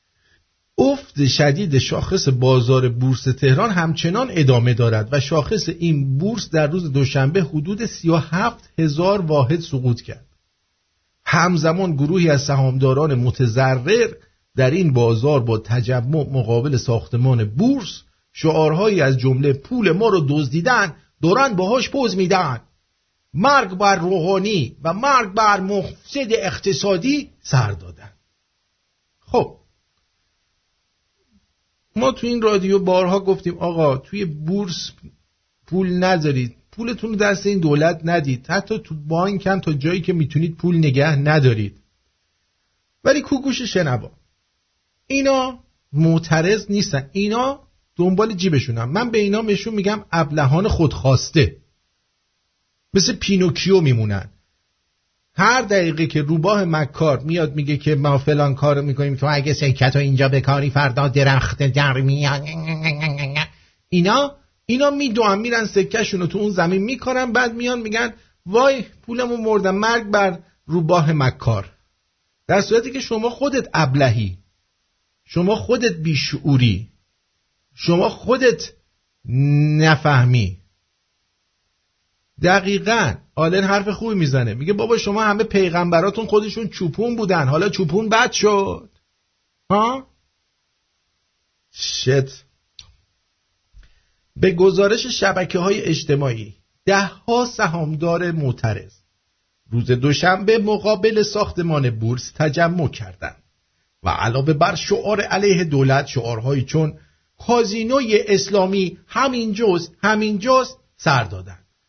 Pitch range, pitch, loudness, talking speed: 130-200 Hz, 160 Hz, -18 LUFS, 110 wpm